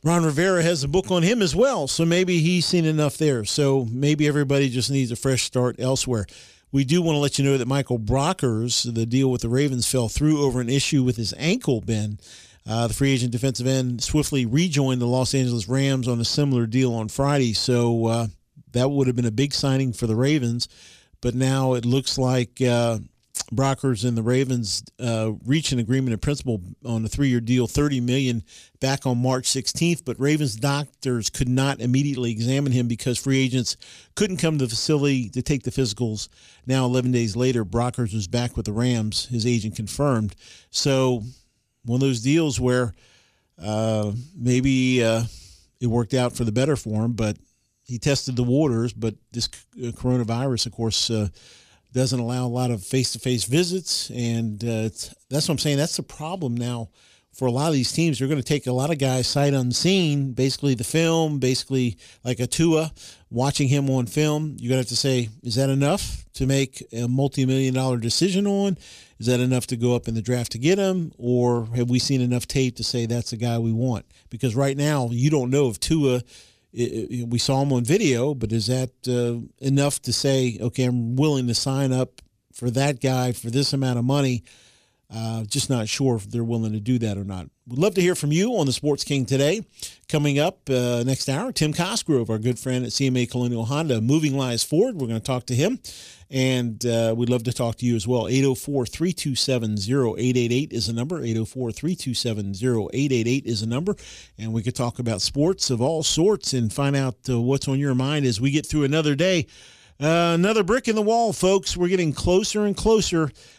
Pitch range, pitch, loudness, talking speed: 120-140 Hz, 130 Hz, -23 LUFS, 205 wpm